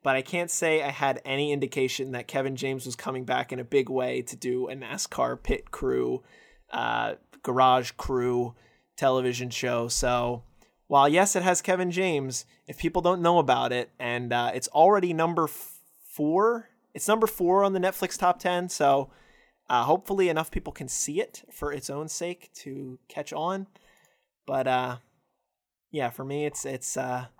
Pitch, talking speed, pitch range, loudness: 140 Hz, 175 wpm, 125-175 Hz, -27 LUFS